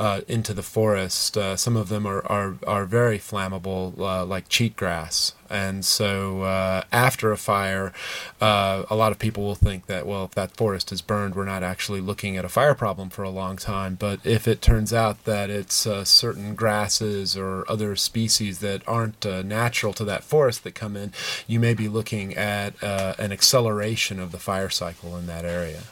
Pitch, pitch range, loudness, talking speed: 100 Hz, 95-110 Hz, -23 LUFS, 200 wpm